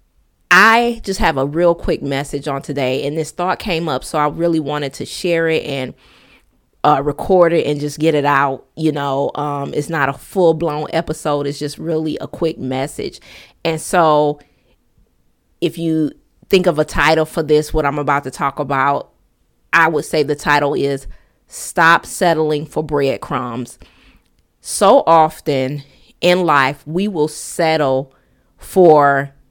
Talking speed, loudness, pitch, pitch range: 160 wpm, -16 LUFS, 150 Hz, 140-165 Hz